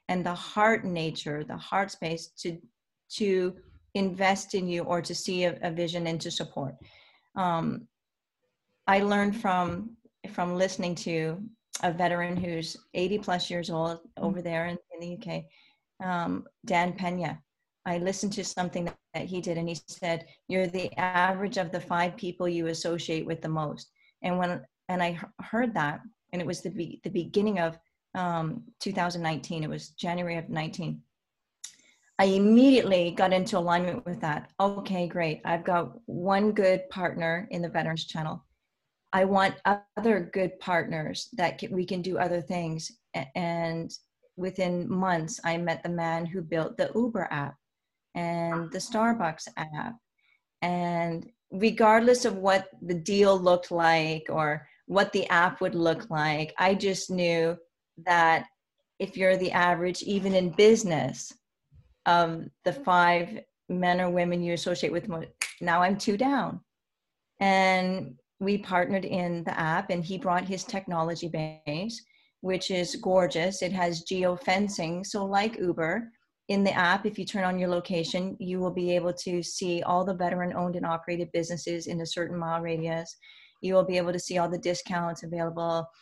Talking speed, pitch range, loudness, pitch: 160 wpm, 170-190 Hz, -28 LUFS, 180 Hz